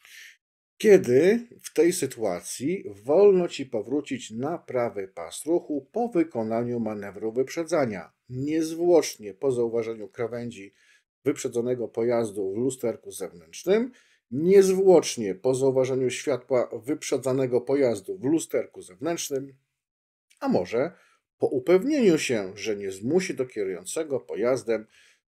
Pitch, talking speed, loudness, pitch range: 135 Hz, 105 wpm, -25 LUFS, 120-190 Hz